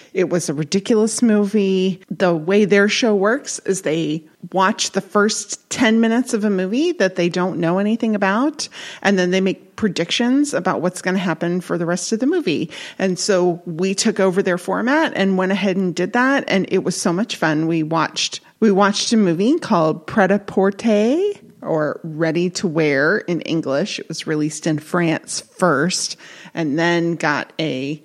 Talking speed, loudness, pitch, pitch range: 185 wpm, -18 LUFS, 190 Hz, 170-215 Hz